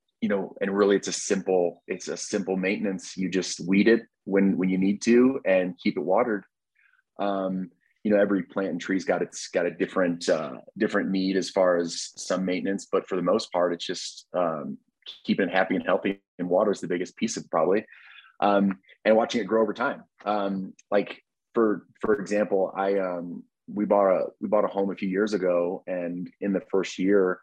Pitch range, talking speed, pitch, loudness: 90-100 Hz, 210 wpm, 95 Hz, -26 LUFS